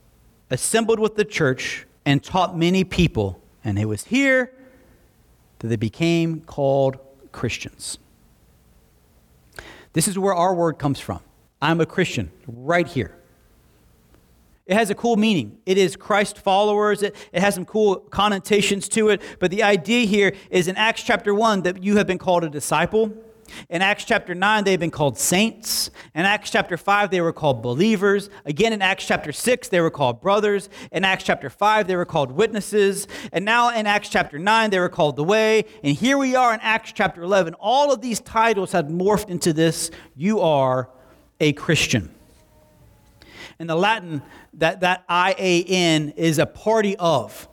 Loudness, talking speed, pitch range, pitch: -20 LUFS, 175 wpm, 155-210 Hz, 185 Hz